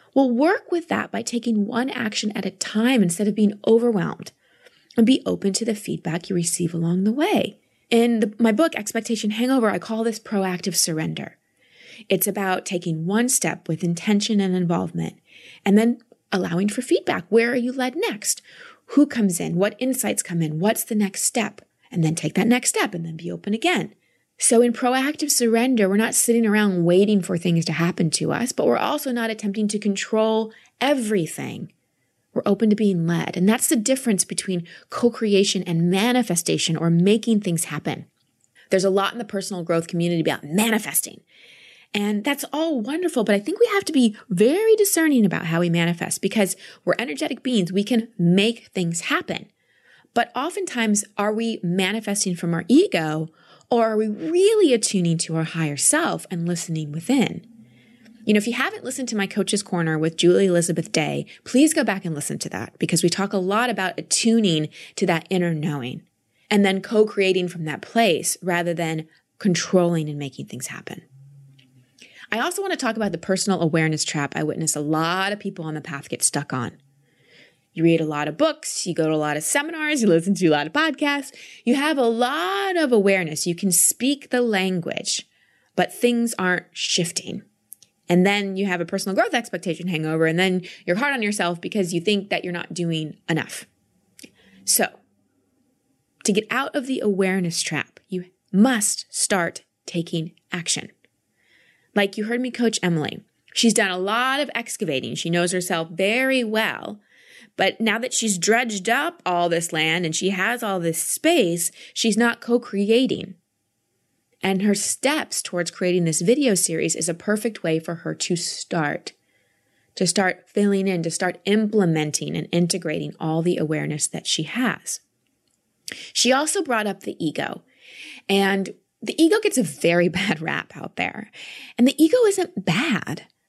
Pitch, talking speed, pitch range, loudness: 200 Hz, 180 wpm, 170-235 Hz, -21 LUFS